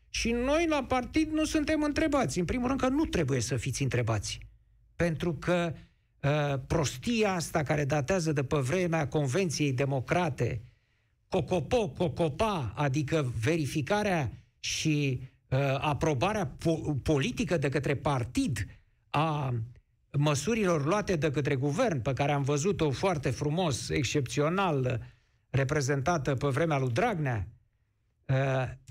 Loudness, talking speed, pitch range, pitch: -30 LUFS, 120 wpm, 130-175 Hz, 150 Hz